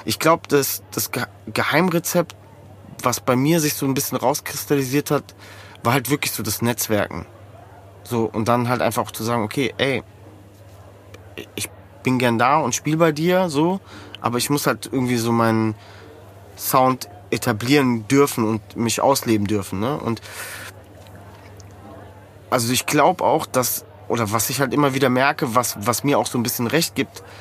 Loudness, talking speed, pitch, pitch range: -20 LUFS, 165 wpm, 115 Hz, 100-135 Hz